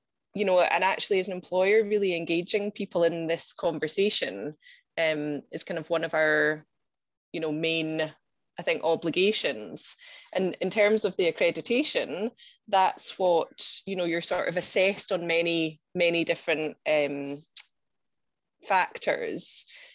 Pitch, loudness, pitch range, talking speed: 170 Hz, -27 LUFS, 160-200 Hz, 140 wpm